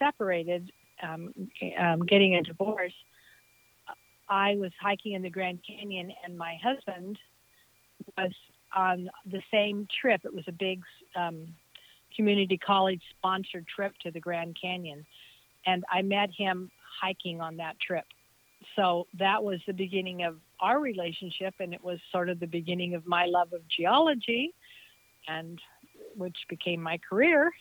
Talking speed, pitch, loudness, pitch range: 145 wpm, 185 Hz, -30 LUFS, 175-200 Hz